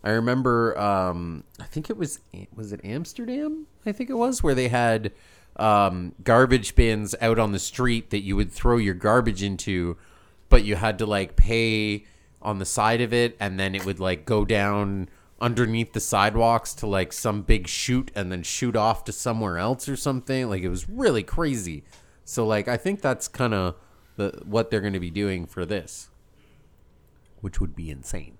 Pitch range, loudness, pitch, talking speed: 95-120 Hz, -25 LUFS, 105 Hz, 190 wpm